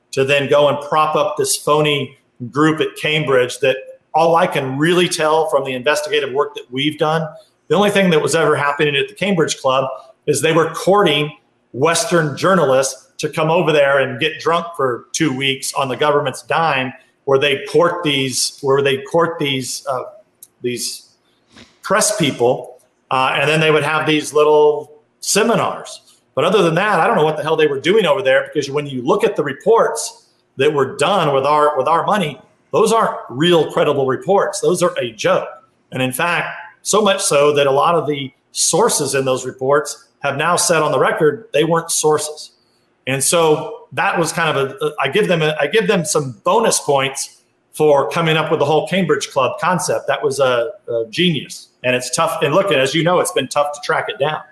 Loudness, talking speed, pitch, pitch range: -16 LUFS, 205 wpm, 150 Hz, 140-170 Hz